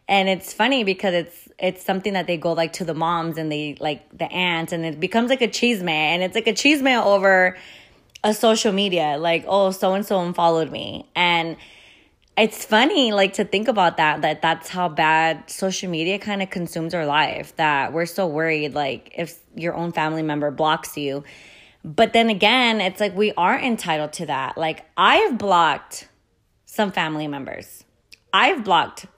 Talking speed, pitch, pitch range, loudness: 185 wpm, 175 Hz, 160-205 Hz, -20 LUFS